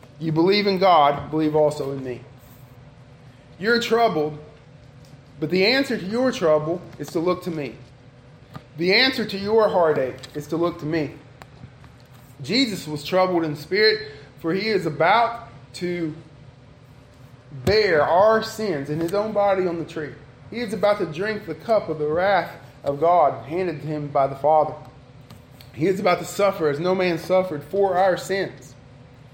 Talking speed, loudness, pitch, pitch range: 165 wpm, -21 LUFS, 155 Hz, 135-190 Hz